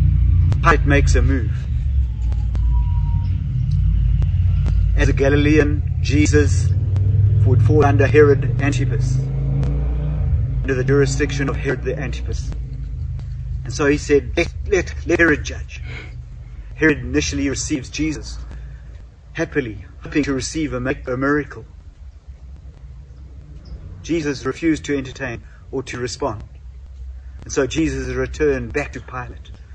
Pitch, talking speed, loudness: 95 Hz, 105 wpm, -19 LUFS